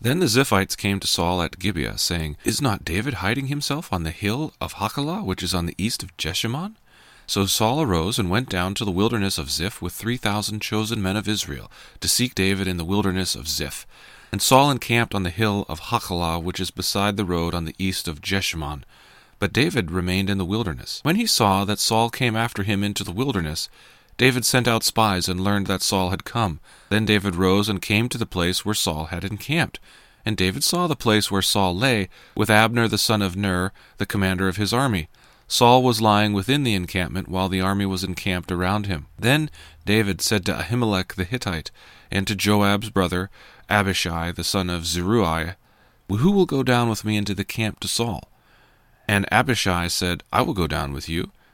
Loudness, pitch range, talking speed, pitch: -22 LUFS, 90-110 Hz, 205 wpm, 100 Hz